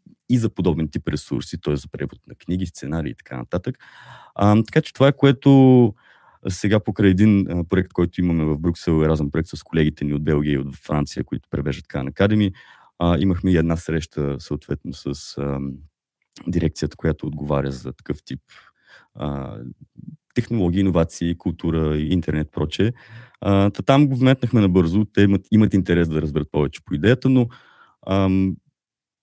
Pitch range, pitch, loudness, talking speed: 75-105 Hz, 85 Hz, -20 LUFS, 170 wpm